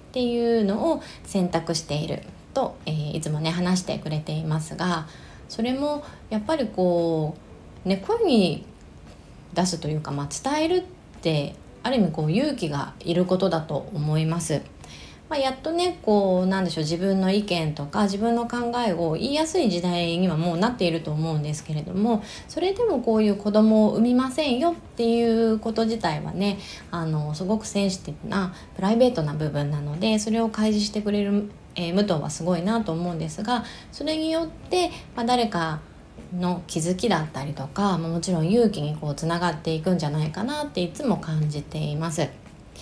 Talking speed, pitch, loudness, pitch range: 360 characters per minute, 185 Hz, -25 LUFS, 160-230 Hz